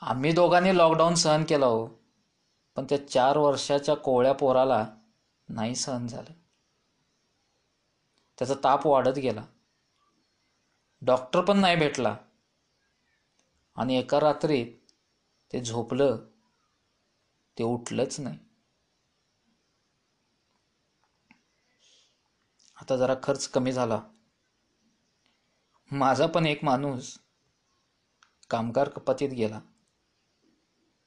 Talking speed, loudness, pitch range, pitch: 85 wpm, -26 LUFS, 125-150 Hz, 135 Hz